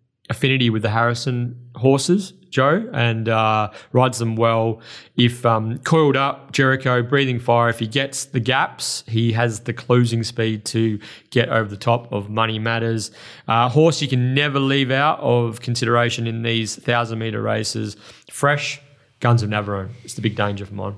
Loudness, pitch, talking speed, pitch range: -20 LUFS, 120 Hz, 170 wpm, 115-135 Hz